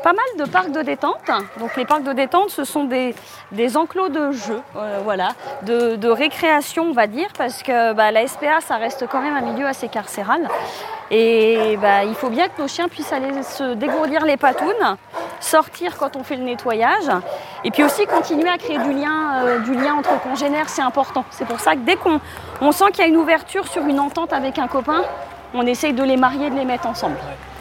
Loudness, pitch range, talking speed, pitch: -19 LUFS, 250-320 Hz, 220 wpm, 280 Hz